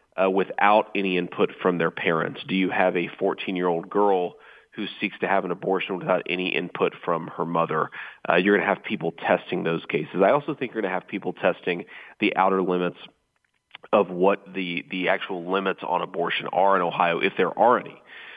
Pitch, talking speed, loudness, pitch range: 90 Hz, 205 wpm, -24 LUFS, 85-95 Hz